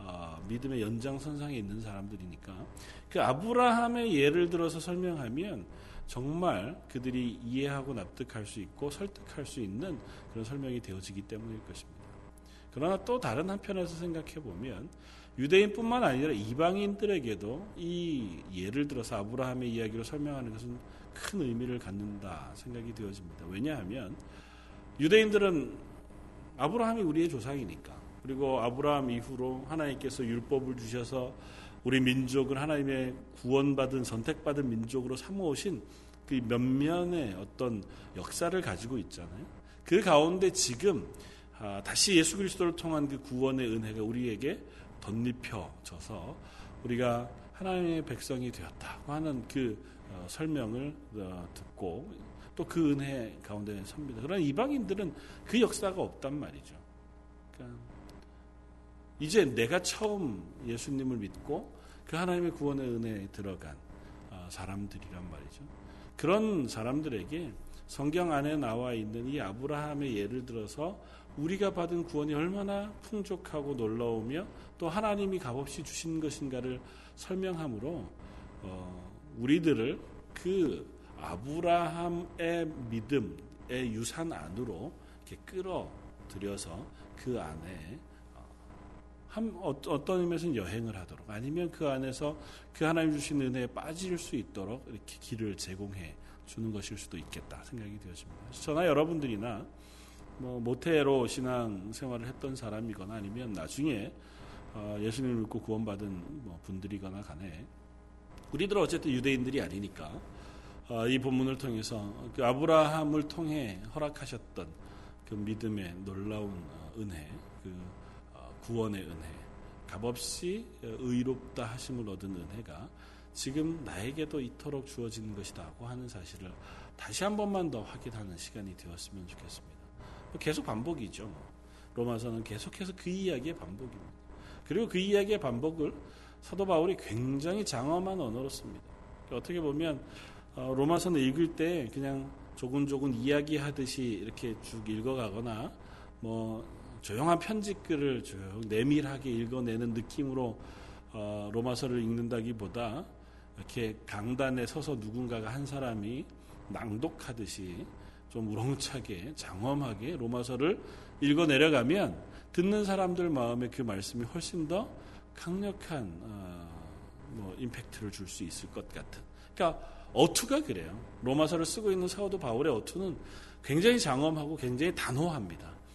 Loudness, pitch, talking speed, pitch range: -34 LUFS, 125 Hz, 300 characters per minute, 100-150 Hz